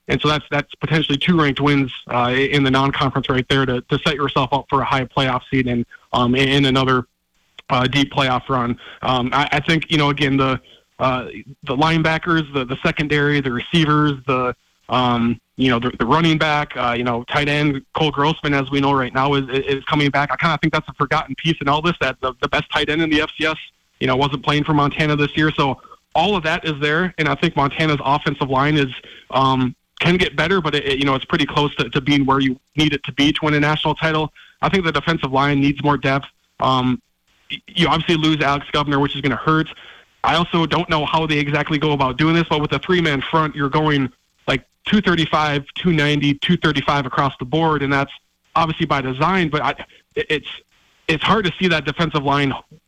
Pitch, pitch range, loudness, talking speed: 145 Hz, 135-155 Hz, -18 LUFS, 230 wpm